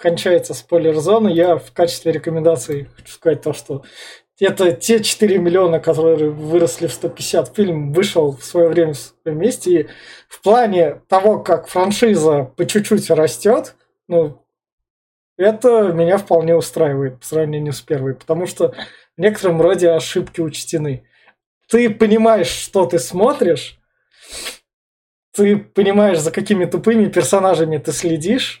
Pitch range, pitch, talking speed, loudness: 160-195 Hz, 170 Hz, 130 wpm, -16 LUFS